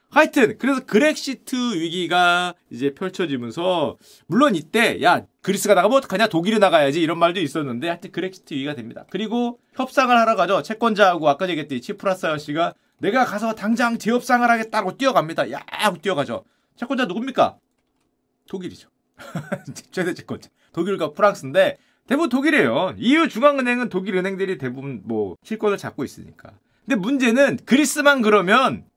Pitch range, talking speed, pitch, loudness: 180-260 Hz, 390 characters per minute, 215 Hz, -20 LUFS